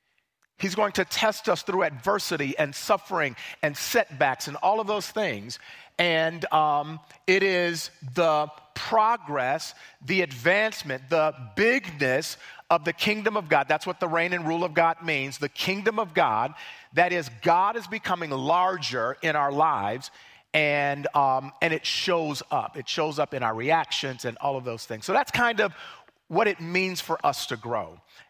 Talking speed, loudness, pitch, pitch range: 170 wpm, -25 LUFS, 170 Hz, 145-190 Hz